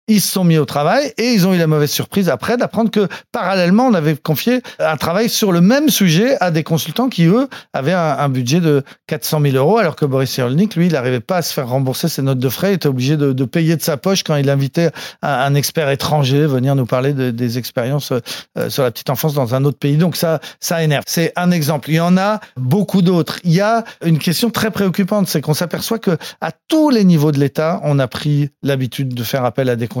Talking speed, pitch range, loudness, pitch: 250 wpm, 140-190 Hz, -16 LUFS, 160 Hz